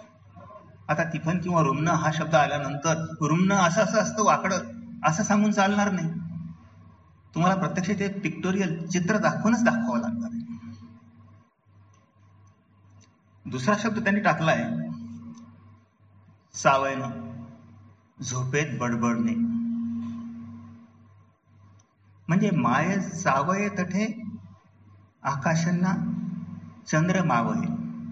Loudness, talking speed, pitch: -25 LUFS, 85 wpm, 160 Hz